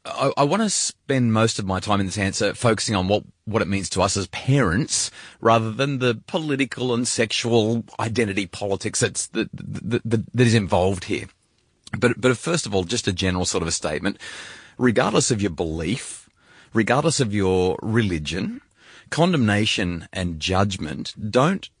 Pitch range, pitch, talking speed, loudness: 100-125 Hz, 110 Hz, 165 wpm, -22 LUFS